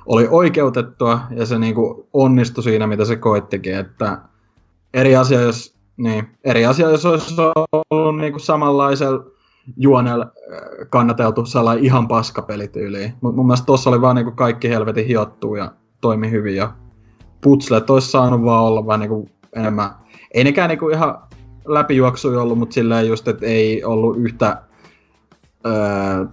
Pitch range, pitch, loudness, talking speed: 110-130 Hz, 115 Hz, -16 LUFS, 140 wpm